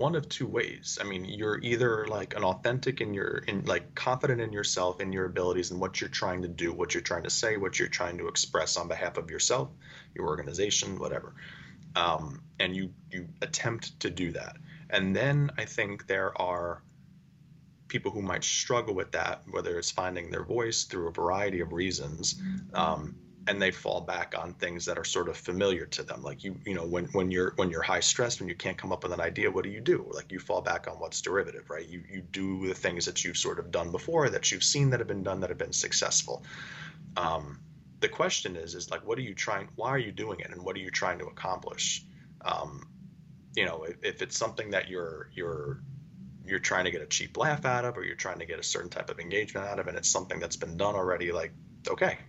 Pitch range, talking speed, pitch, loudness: 90-145 Hz, 235 wpm, 105 Hz, -31 LUFS